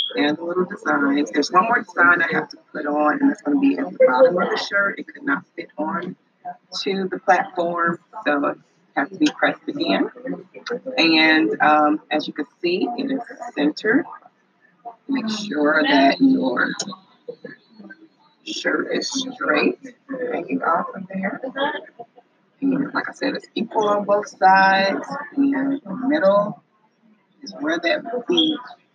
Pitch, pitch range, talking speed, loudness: 240 Hz, 190-280 Hz, 160 wpm, -20 LUFS